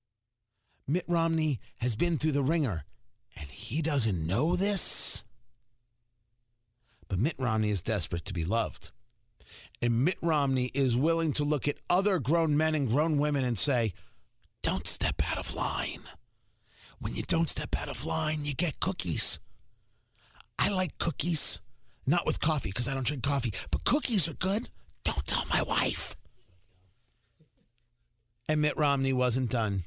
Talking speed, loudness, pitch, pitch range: 150 wpm, -29 LUFS, 125 Hz, 110-155 Hz